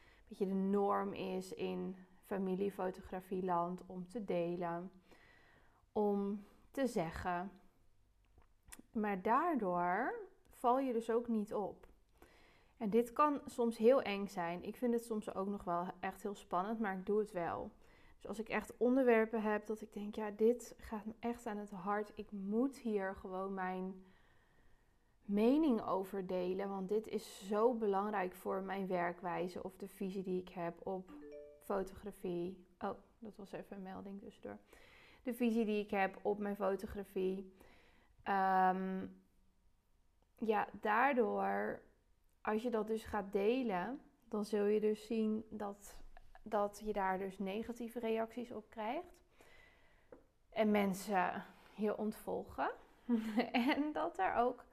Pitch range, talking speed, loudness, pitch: 185-225 Hz, 145 wpm, -39 LUFS, 205 Hz